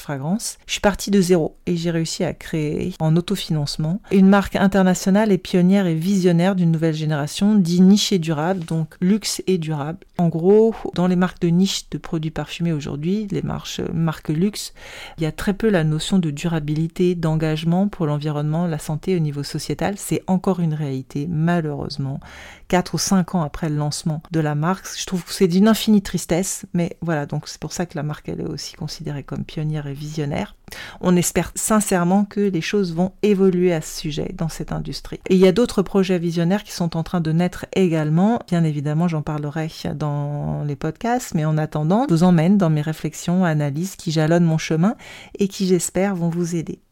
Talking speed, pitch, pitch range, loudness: 200 wpm, 170 Hz, 155-190 Hz, -20 LUFS